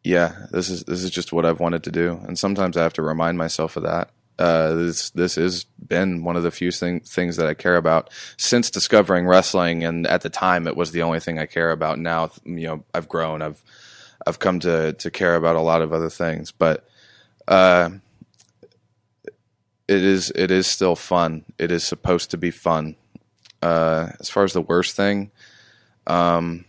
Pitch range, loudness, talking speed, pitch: 80-90 Hz, -21 LUFS, 200 wpm, 85 Hz